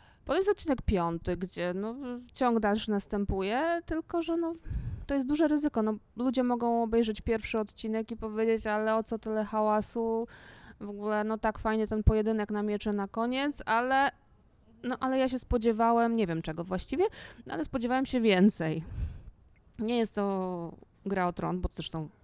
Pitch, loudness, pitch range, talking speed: 225 Hz, -30 LUFS, 205-250 Hz, 165 wpm